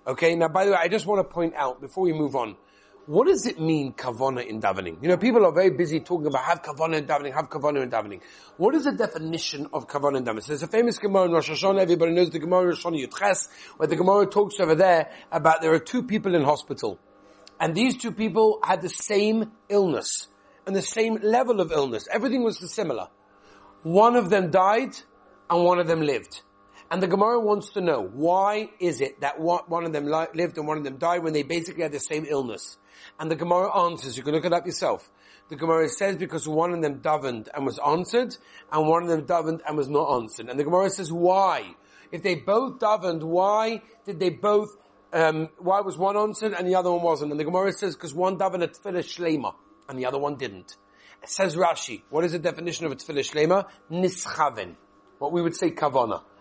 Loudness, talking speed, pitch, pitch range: -24 LUFS, 225 wpm, 170 Hz, 155-195 Hz